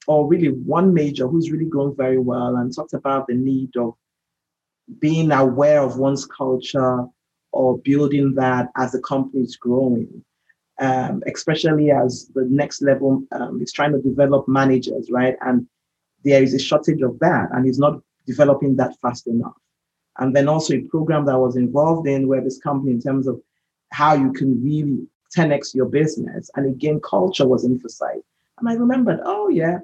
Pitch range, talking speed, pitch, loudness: 130-150 Hz, 175 wpm, 135 Hz, -19 LUFS